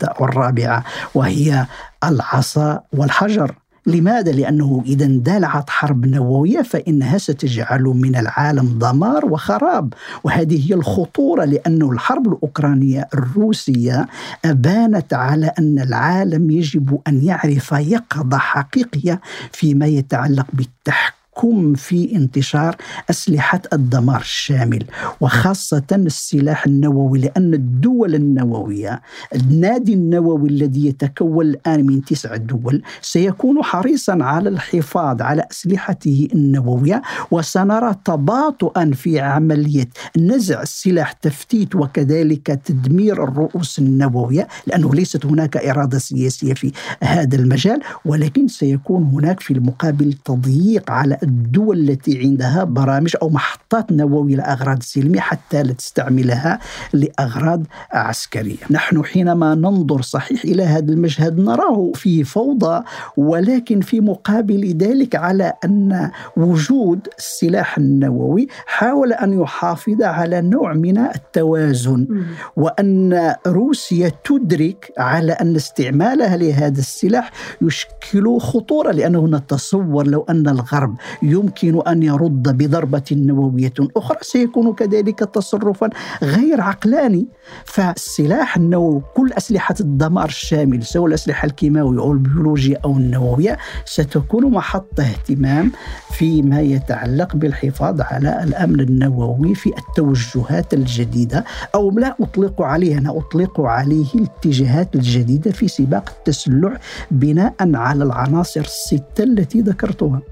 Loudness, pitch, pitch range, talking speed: -16 LUFS, 155 Hz, 140-185 Hz, 105 wpm